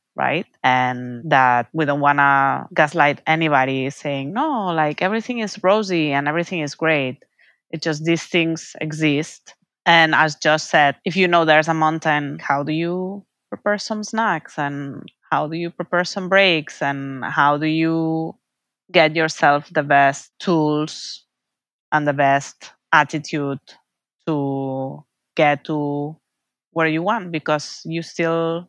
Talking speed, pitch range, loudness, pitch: 145 wpm, 145-170 Hz, -19 LUFS, 155 Hz